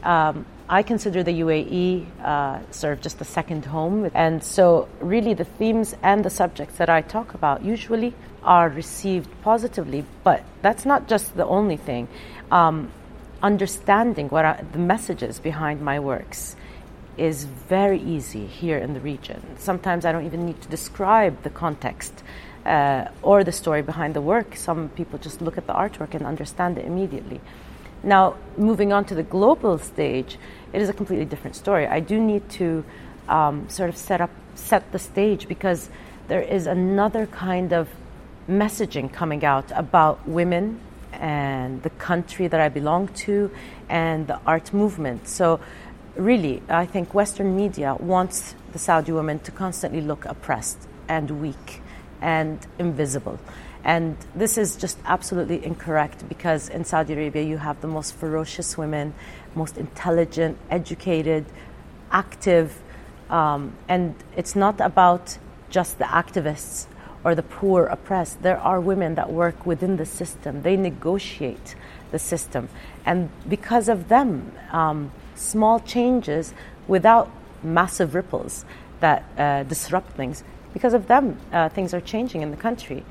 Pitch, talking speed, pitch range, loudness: 170 Hz, 150 wpm, 155-195 Hz, -23 LUFS